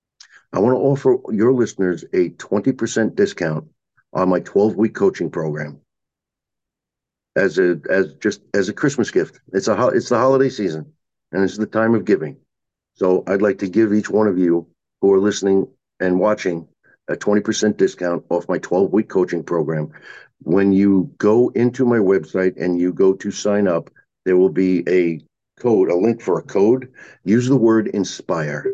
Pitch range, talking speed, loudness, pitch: 90-110 Hz, 175 wpm, -18 LUFS, 95 Hz